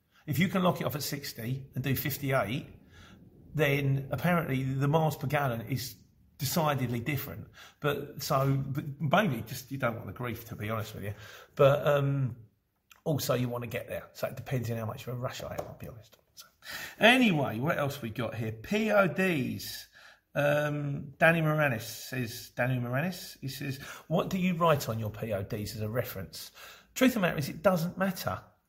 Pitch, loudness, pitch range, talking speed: 135 Hz, -30 LUFS, 115-150 Hz, 190 wpm